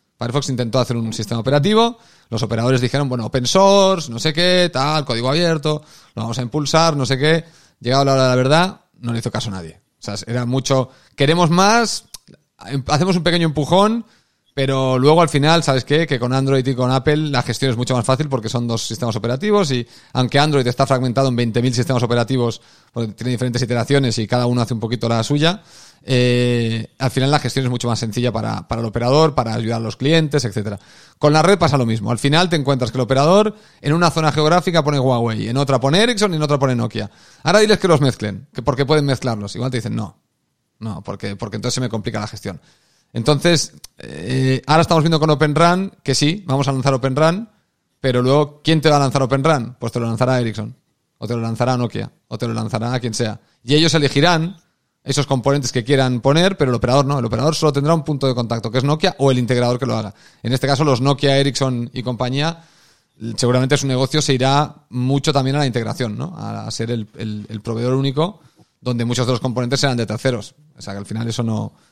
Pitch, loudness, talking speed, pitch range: 130 Hz, -17 LUFS, 225 wpm, 120-150 Hz